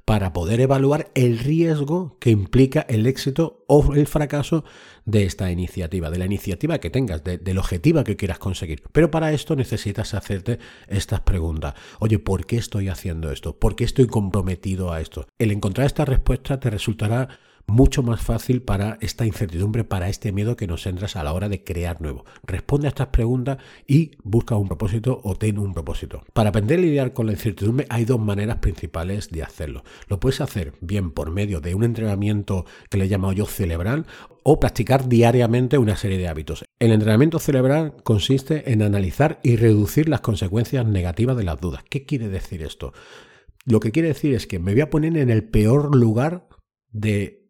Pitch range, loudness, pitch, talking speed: 95-130 Hz, -21 LUFS, 110 Hz, 190 wpm